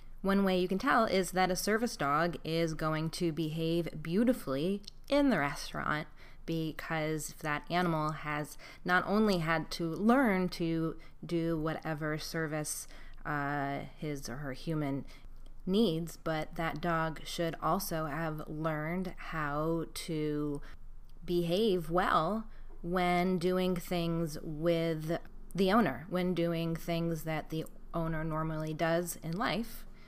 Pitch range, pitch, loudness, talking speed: 155-180 Hz, 165 Hz, -33 LUFS, 130 wpm